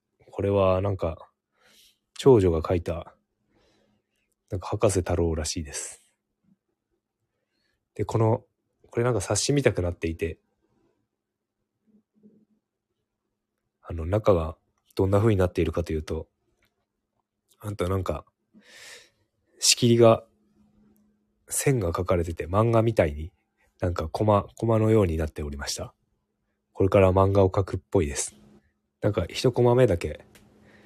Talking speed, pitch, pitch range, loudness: 245 characters per minute, 100 Hz, 85-110 Hz, -24 LUFS